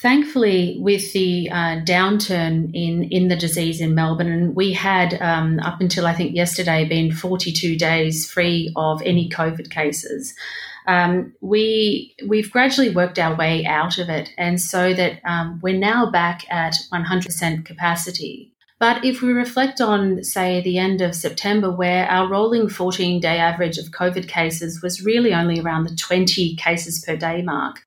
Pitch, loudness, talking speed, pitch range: 175 Hz, -19 LUFS, 165 wpm, 165-185 Hz